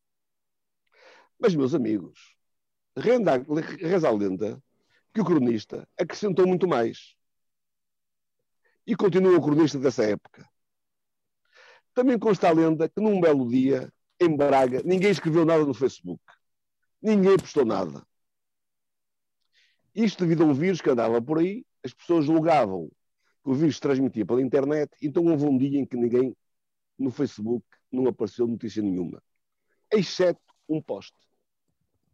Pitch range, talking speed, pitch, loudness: 130-195 Hz, 135 wpm, 160 Hz, -24 LUFS